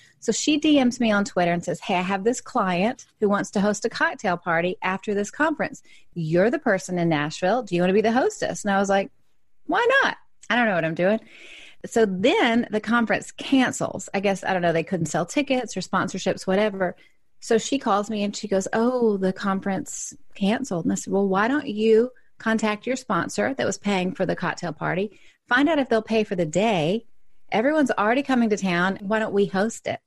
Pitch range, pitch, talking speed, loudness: 185-235 Hz, 205 Hz, 220 wpm, -23 LUFS